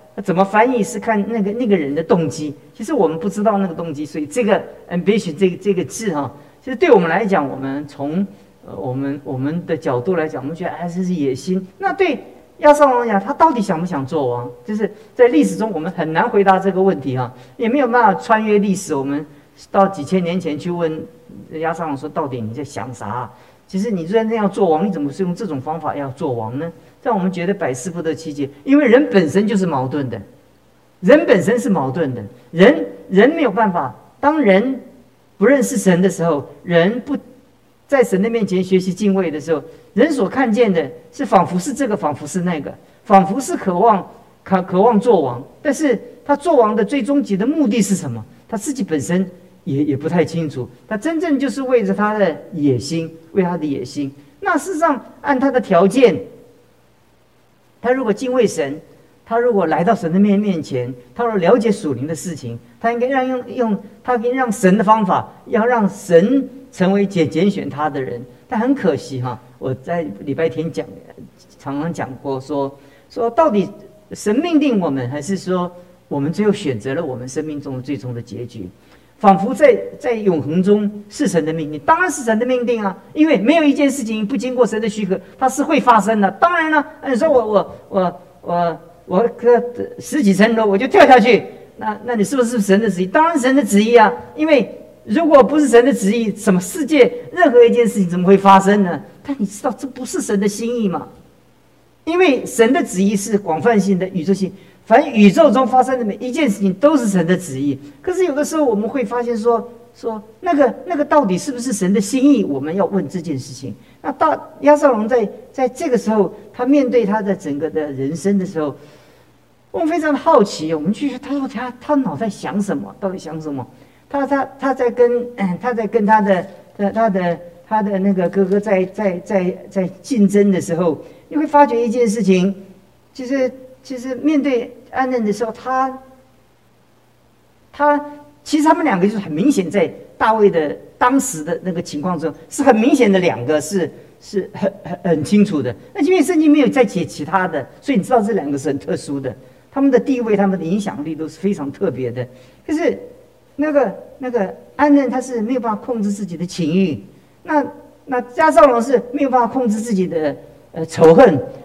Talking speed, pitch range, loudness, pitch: 290 characters per minute, 165-250 Hz, -17 LUFS, 200 Hz